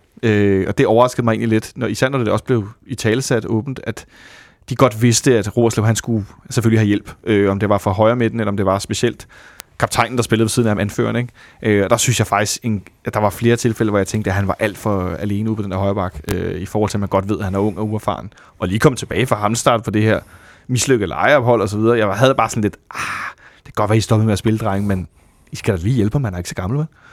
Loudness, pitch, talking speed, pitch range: -17 LUFS, 110 Hz, 290 wpm, 100-120 Hz